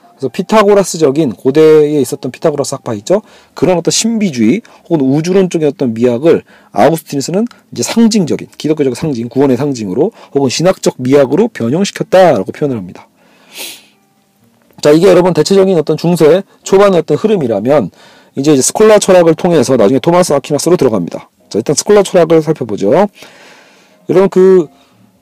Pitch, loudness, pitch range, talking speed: 160 Hz, -10 LUFS, 140-190 Hz, 390 characters per minute